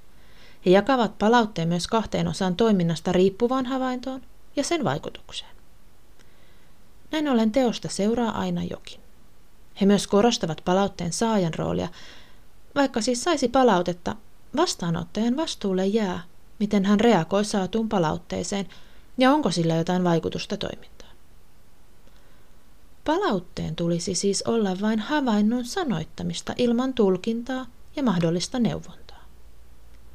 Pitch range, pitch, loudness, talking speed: 180-240 Hz, 205 Hz, -24 LUFS, 105 wpm